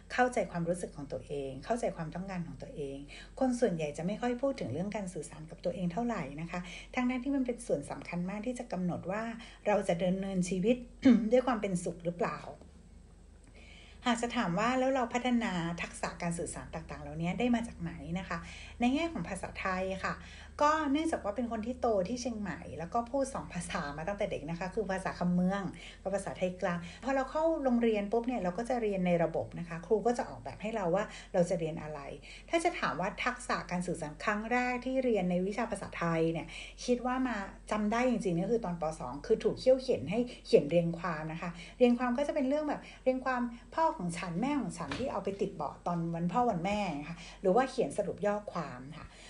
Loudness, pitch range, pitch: -33 LUFS, 175-245 Hz, 200 Hz